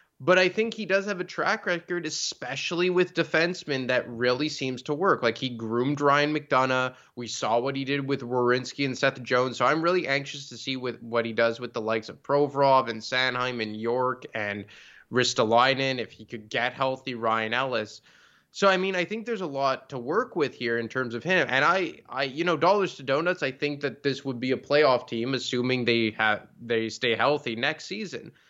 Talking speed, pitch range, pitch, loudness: 210 wpm, 120-150 Hz, 130 Hz, -26 LUFS